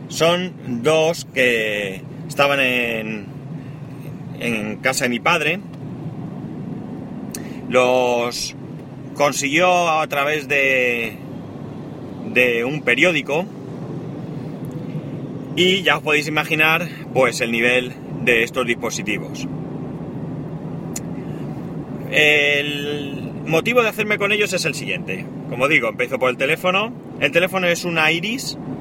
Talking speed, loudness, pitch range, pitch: 100 wpm, -19 LUFS, 130-160 Hz, 145 Hz